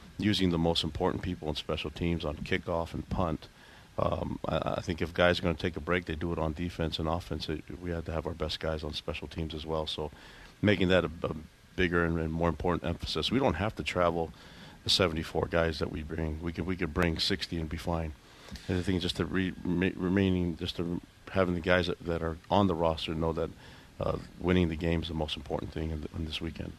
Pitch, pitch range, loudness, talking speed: 85 Hz, 80-90 Hz, -31 LUFS, 245 wpm